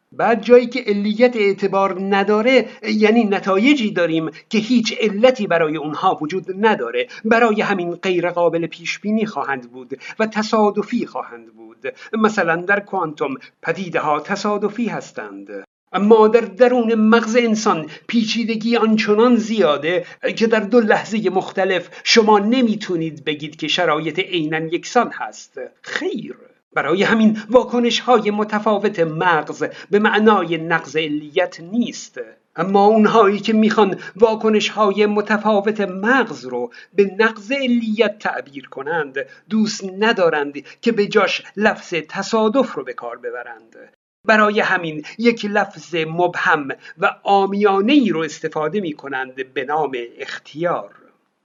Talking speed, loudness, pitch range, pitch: 125 wpm, -18 LUFS, 170-225 Hz, 205 Hz